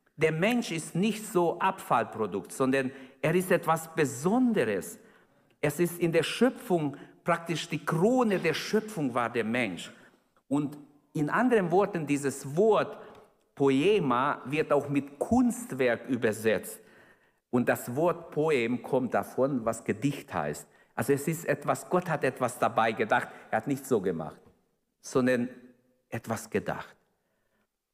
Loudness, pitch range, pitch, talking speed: -29 LUFS, 135-175 Hz, 150 Hz, 135 wpm